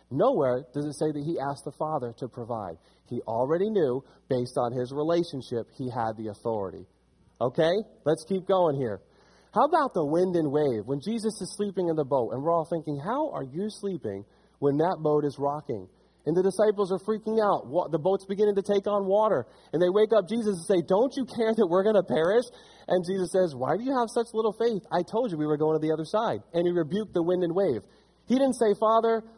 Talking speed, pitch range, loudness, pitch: 230 wpm, 145-210 Hz, -27 LUFS, 175 Hz